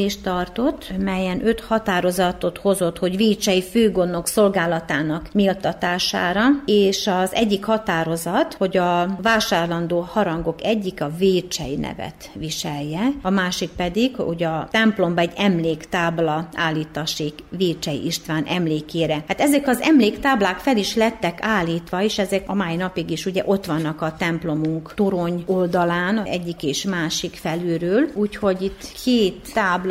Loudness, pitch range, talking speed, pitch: -21 LUFS, 165-205 Hz, 130 wpm, 180 Hz